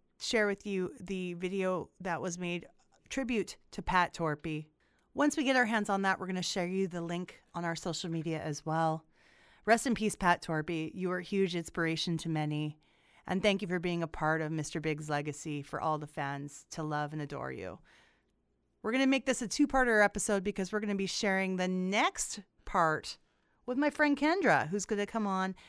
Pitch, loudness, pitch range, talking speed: 185 Hz, -33 LUFS, 160-205 Hz, 210 wpm